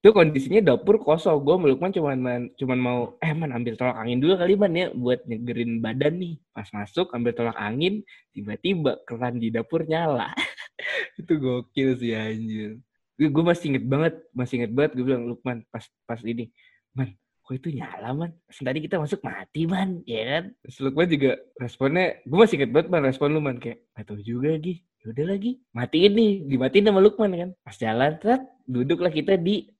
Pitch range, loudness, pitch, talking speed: 120-175 Hz, -24 LUFS, 140 Hz, 185 wpm